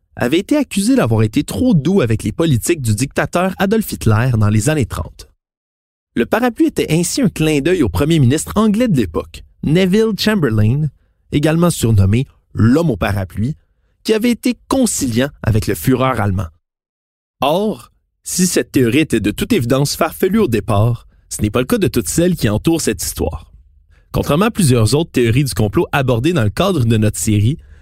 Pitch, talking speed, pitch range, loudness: 125 Hz, 180 wpm, 105-175 Hz, -15 LUFS